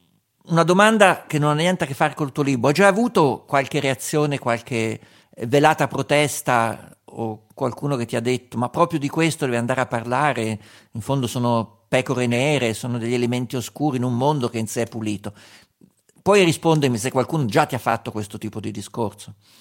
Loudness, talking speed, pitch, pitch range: -21 LUFS, 195 wpm, 125 Hz, 115-150 Hz